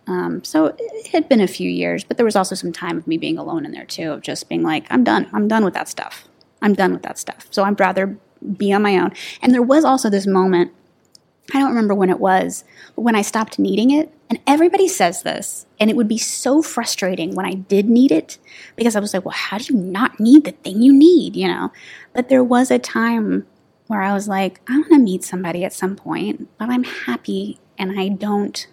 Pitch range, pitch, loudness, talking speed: 190-265 Hz, 215 Hz, -17 LUFS, 255 wpm